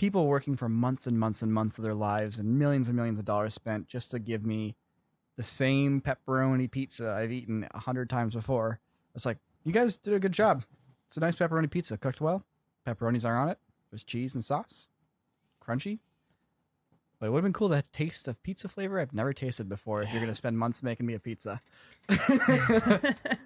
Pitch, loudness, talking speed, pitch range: 125 Hz, -30 LUFS, 210 wpm, 110-155 Hz